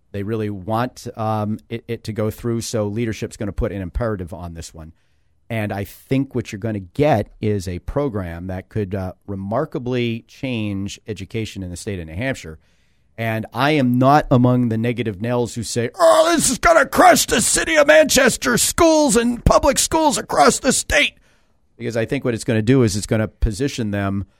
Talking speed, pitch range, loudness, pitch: 205 wpm, 100-130 Hz, -18 LUFS, 115 Hz